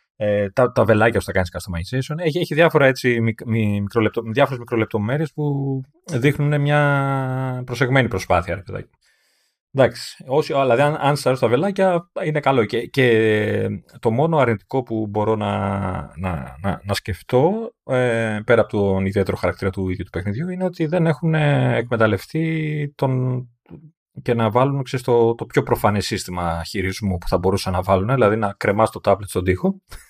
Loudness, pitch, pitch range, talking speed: -20 LUFS, 120 Hz, 100-140 Hz, 155 wpm